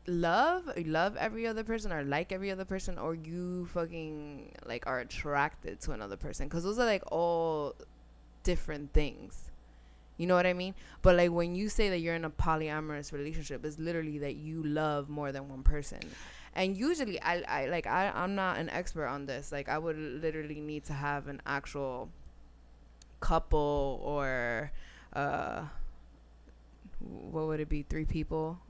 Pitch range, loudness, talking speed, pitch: 140-175 Hz, -34 LUFS, 170 wpm, 155 Hz